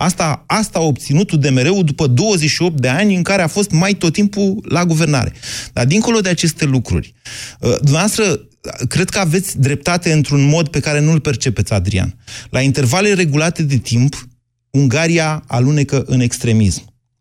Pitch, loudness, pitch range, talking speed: 145 Hz, -15 LUFS, 125-175 Hz, 155 wpm